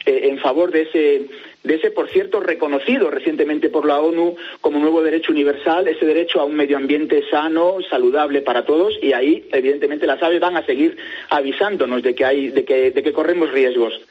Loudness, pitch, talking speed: -17 LUFS, 170 Hz, 190 wpm